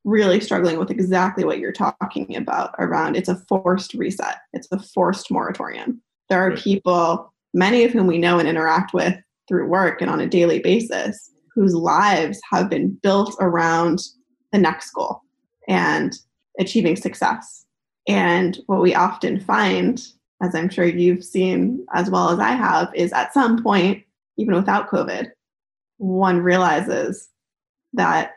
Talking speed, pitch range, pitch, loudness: 150 wpm, 180-200 Hz, 185 Hz, -20 LUFS